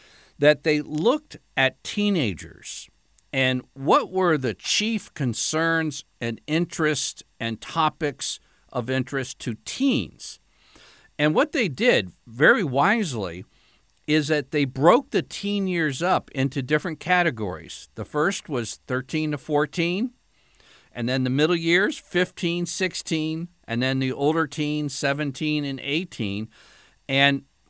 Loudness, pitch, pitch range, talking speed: -24 LUFS, 150 Hz, 130-165 Hz, 125 wpm